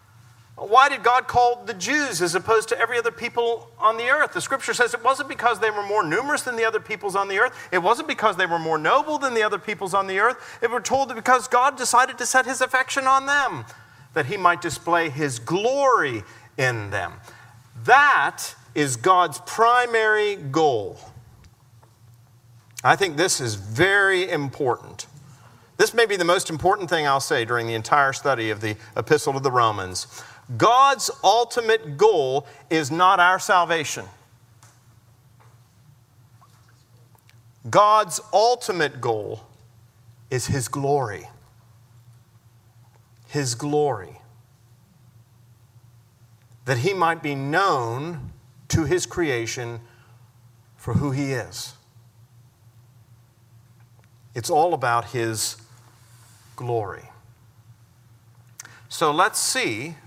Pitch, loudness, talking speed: 130 Hz, -21 LUFS, 130 wpm